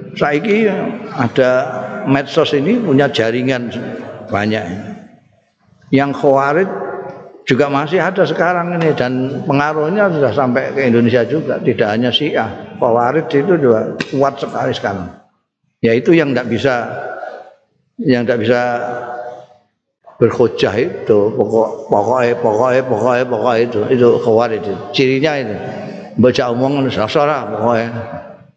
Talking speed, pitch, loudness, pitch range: 105 wpm, 135 Hz, -15 LUFS, 120-145 Hz